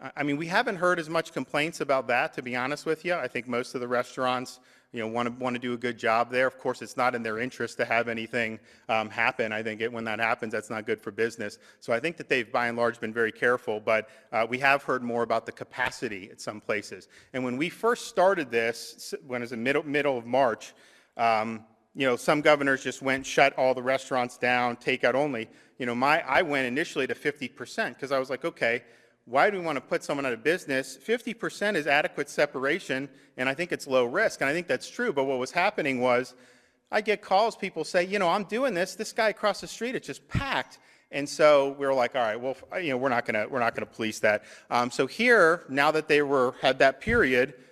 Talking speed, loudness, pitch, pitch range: 245 wpm, -27 LUFS, 130 Hz, 120-150 Hz